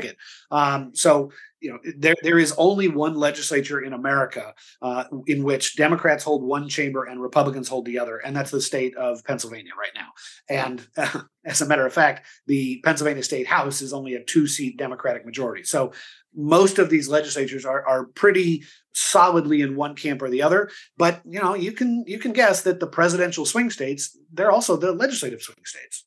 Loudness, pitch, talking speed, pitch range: -22 LUFS, 150 Hz, 190 wpm, 135-170 Hz